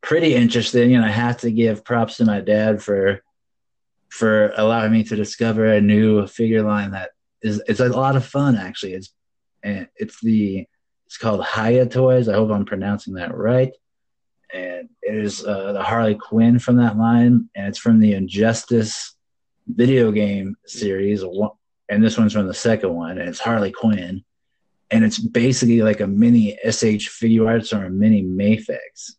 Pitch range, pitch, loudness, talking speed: 105-120 Hz, 110 Hz, -18 LUFS, 175 wpm